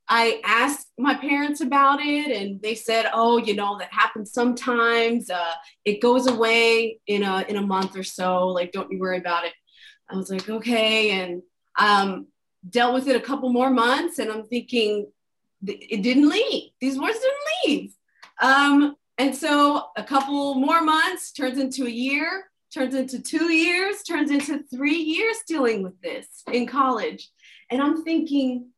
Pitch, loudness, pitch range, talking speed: 250 Hz, -22 LUFS, 215-285 Hz, 170 wpm